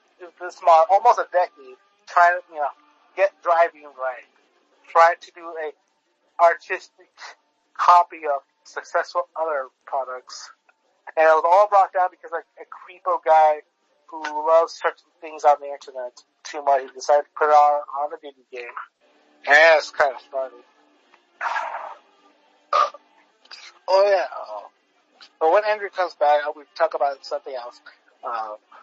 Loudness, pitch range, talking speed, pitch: -20 LUFS, 145-180 Hz, 150 wpm, 160 Hz